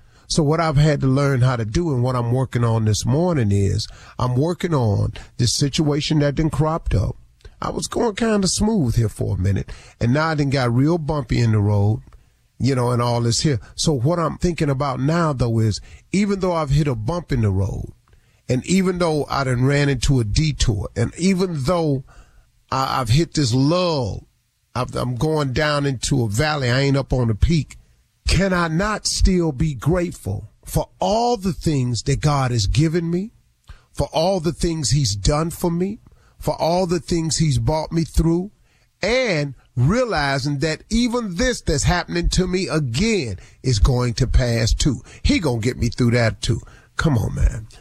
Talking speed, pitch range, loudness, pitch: 190 wpm, 120-165 Hz, -20 LUFS, 140 Hz